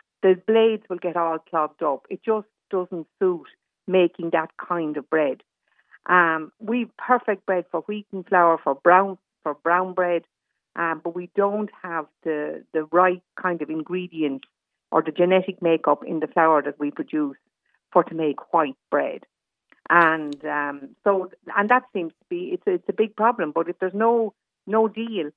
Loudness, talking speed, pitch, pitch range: -23 LUFS, 175 wpm, 180 Hz, 160-200 Hz